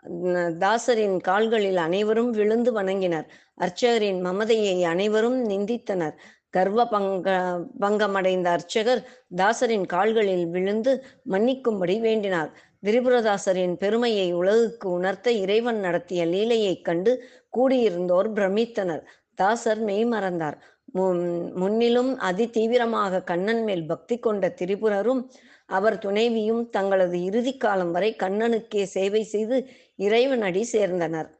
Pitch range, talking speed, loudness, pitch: 185-230 Hz, 90 wpm, -24 LUFS, 205 Hz